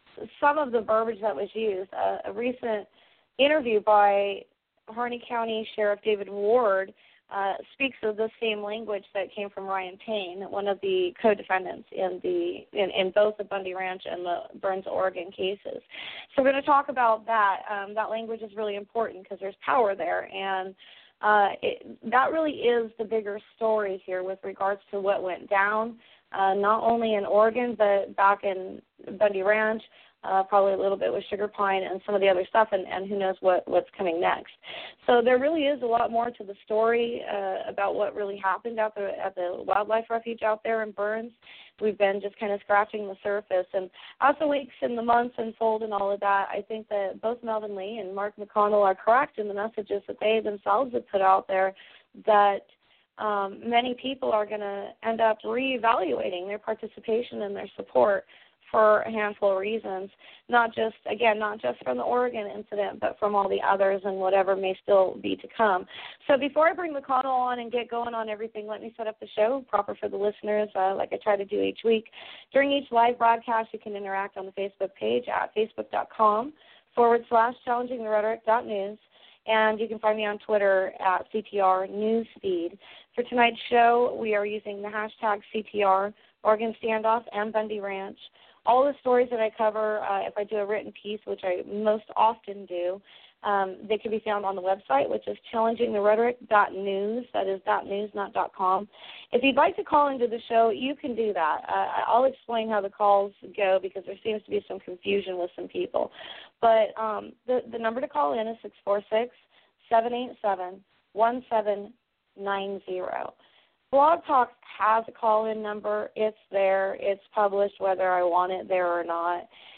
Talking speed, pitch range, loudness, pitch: 195 wpm, 195-230 Hz, -26 LUFS, 210 Hz